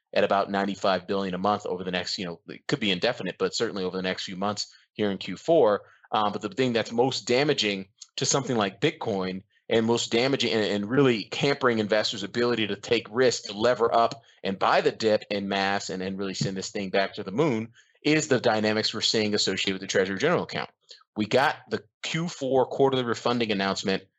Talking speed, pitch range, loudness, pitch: 210 wpm, 100-120 Hz, -26 LUFS, 110 Hz